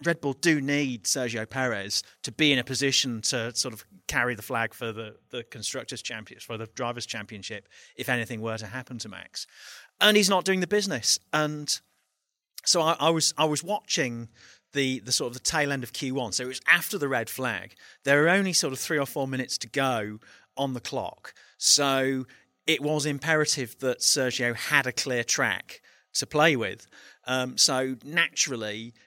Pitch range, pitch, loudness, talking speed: 115-145 Hz, 130 Hz, -26 LUFS, 190 wpm